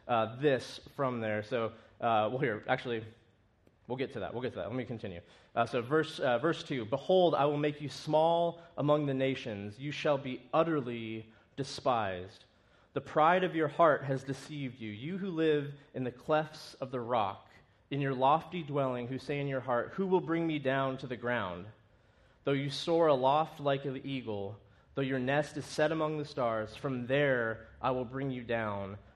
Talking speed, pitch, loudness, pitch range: 200 wpm, 135 Hz, -33 LUFS, 115-150 Hz